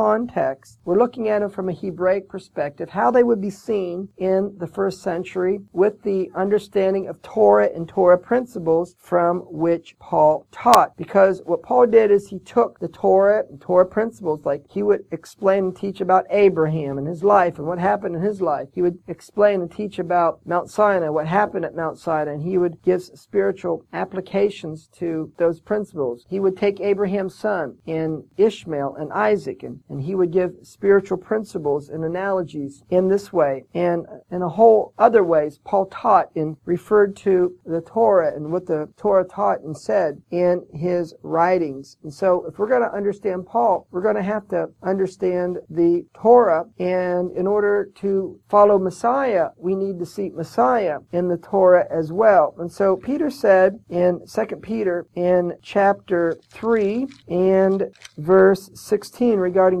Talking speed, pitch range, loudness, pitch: 170 wpm, 170-200 Hz, -20 LUFS, 185 Hz